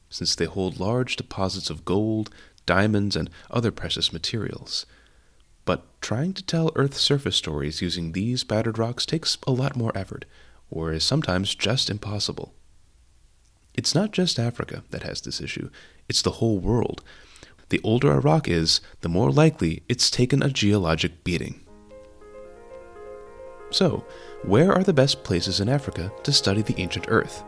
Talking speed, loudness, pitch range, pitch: 155 wpm, -24 LUFS, 90-130 Hz, 105 Hz